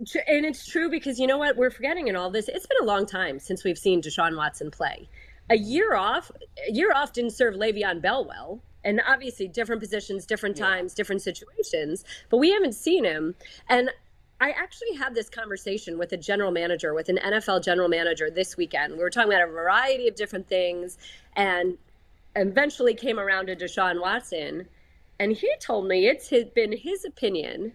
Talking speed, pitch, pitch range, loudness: 190 wpm, 215 Hz, 185-270 Hz, -25 LUFS